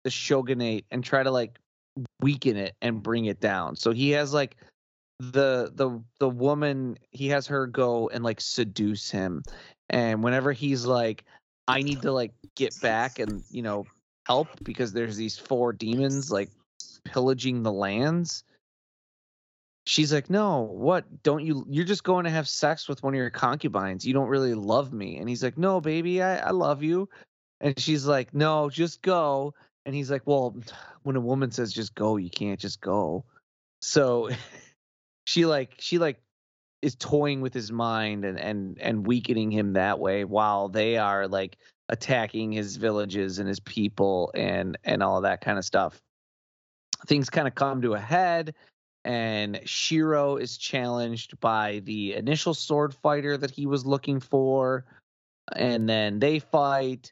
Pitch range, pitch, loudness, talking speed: 110-145 Hz, 125 Hz, -27 LUFS, 170 wpm